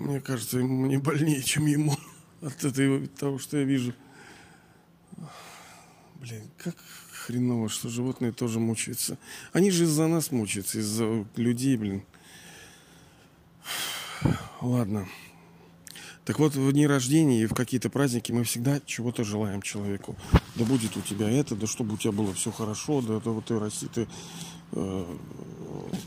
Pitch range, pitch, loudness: 110-140 Hz, 125 Hz, -28 LUFS